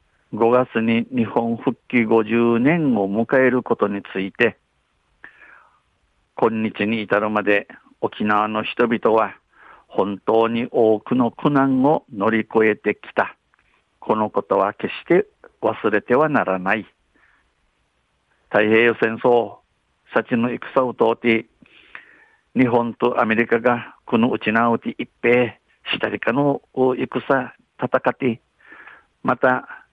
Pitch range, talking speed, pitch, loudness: 105-125 Hz, 205 characters per minute, 115 Hz, -20 LUFS